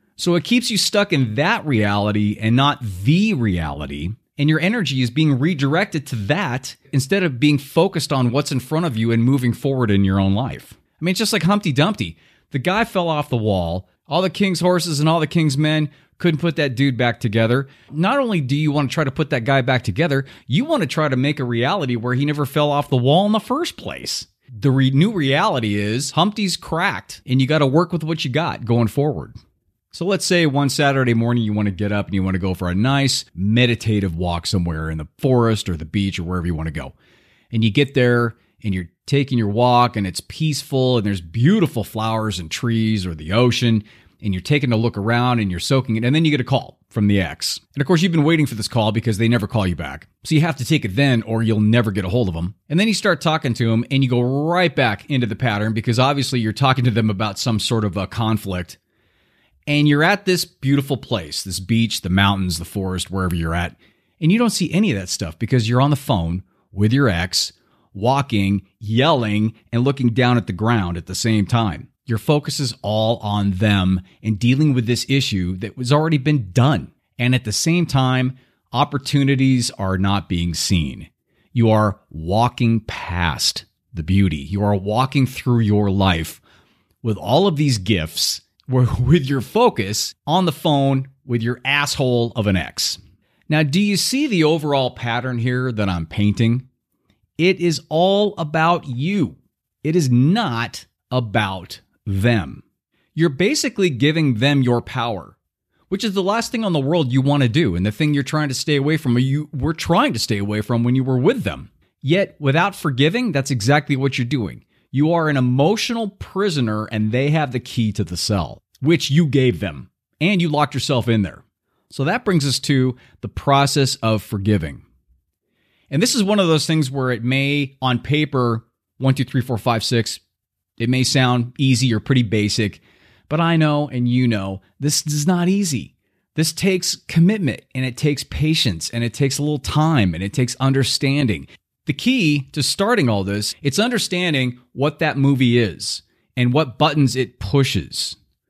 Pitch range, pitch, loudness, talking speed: 105-150 Hz, 125 Hz, -19 LUFS, 210 wpm